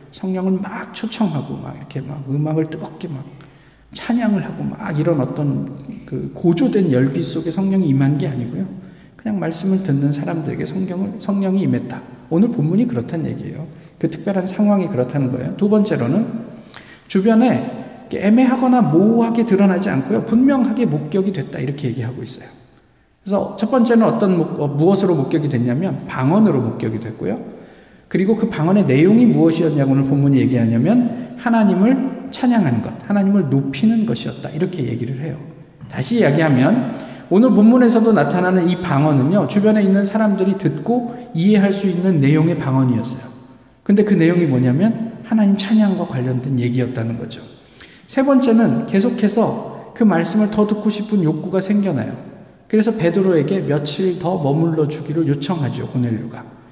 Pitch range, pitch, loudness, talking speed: 140-210 Hz, 180 Hz, -17 LUFS, 360 characters per minute